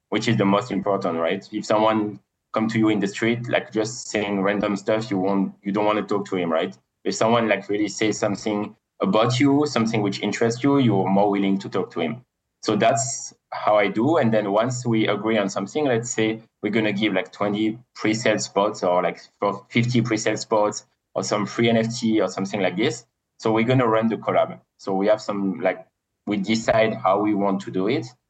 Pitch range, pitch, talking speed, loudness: 100-110 Hz, 105 Hz, 220 wpm, -22 LUFS